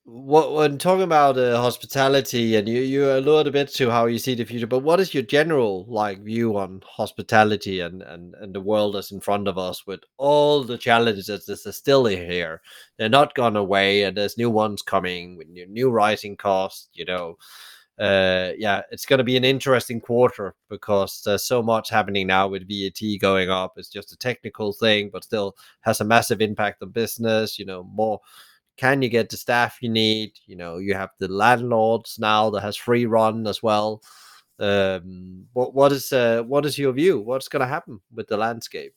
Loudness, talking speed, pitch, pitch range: -21 LUFS, 205 wpm, 110 Hz, 100-125 Hz